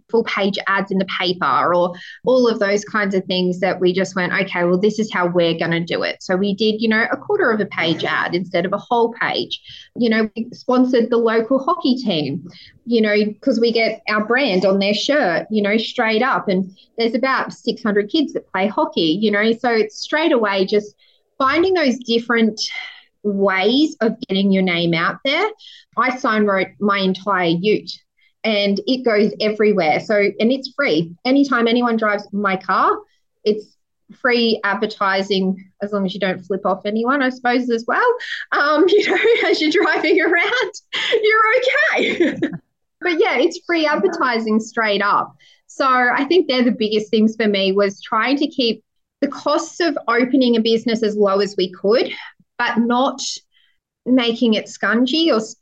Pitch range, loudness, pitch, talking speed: 200-265 Hz, -18 LUFS, 225 Hz, 185 wpm